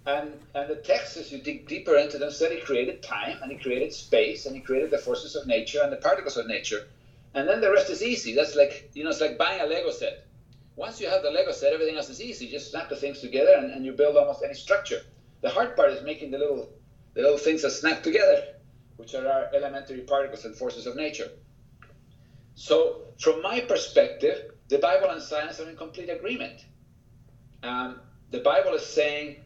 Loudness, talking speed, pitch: -26 LUFS, 220 wpm, 150 Hz